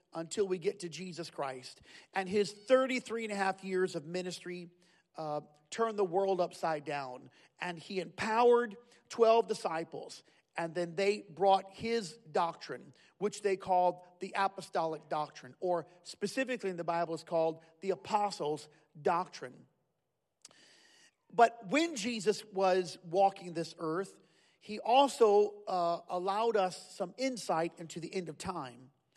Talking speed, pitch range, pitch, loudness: 140 wpm, 170-210 Hz, 185 Hz, -34 LUFS